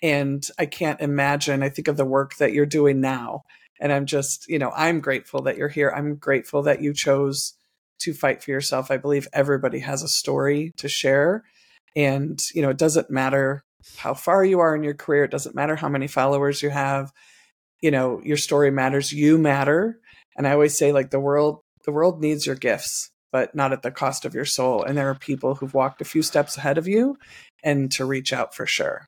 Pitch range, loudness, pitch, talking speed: 135-150 Hz, -22 LUFS, 140 Hz, 220 wpm